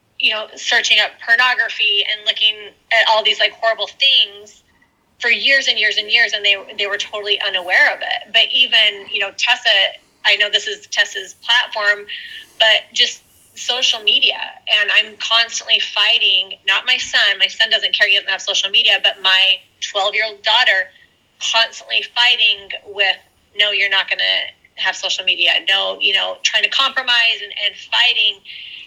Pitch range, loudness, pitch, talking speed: 200-245 Hz, -14 LUFS, 215 Hz, 175 wpm